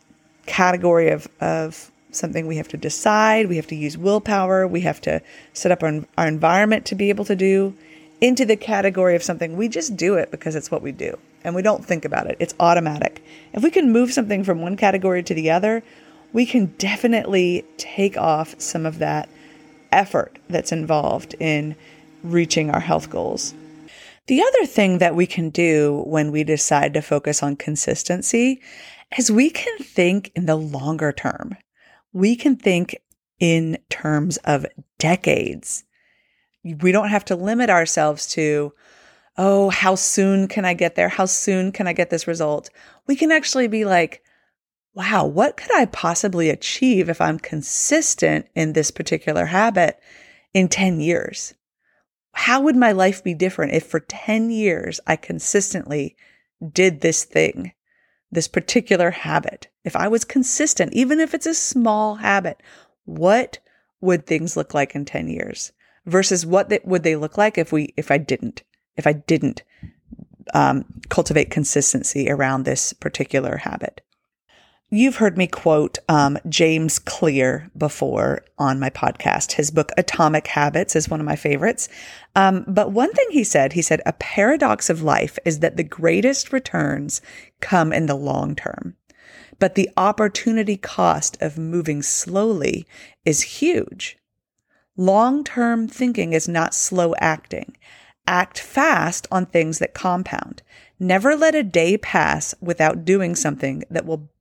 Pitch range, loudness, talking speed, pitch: 155-210 Hz, -19 LUFS, 160 wpm, 180 Hz